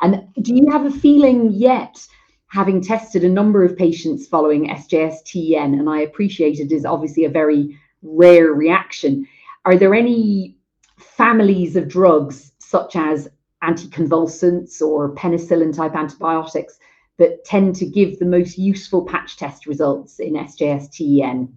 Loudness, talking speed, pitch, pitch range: -16 LUFS, 140 wpm, 170 Hz, 155-195 Hz